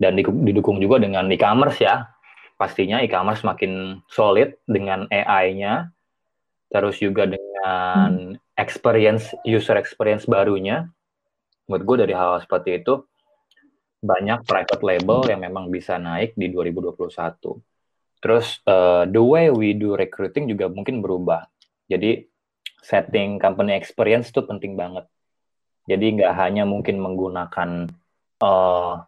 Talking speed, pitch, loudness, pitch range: 120 wpm, 100 Hz, -20 LUFS, 90-115 Hz